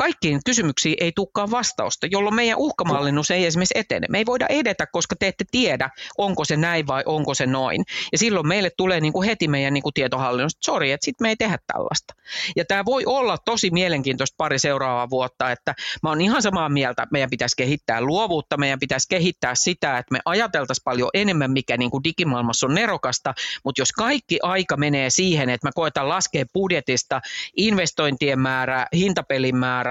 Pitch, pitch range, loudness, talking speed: 155 Hz, 135-190 Hz, -21 LUFS, 190 wpm